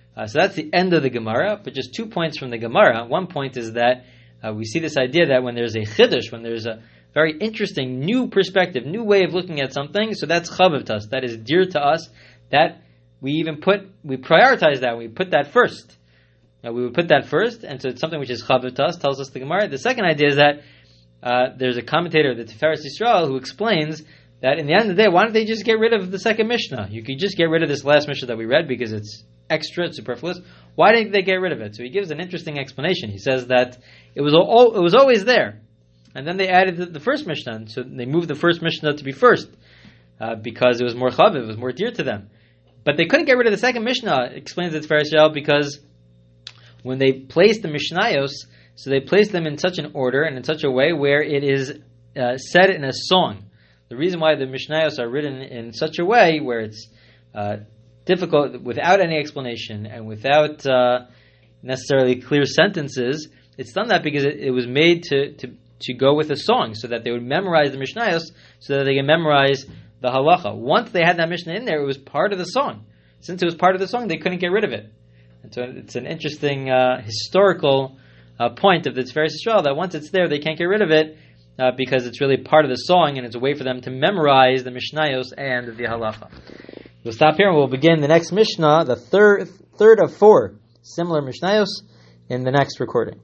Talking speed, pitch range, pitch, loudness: 230 wpm, 120-170 Hz, 140 Hz, -19 LUFS